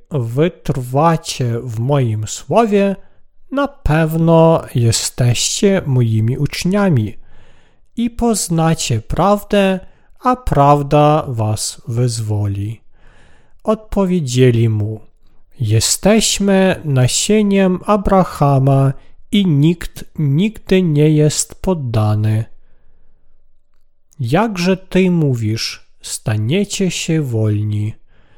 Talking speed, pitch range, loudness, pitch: 70 wpm, 115-190 Hz, -15 LUFS, 145 Hz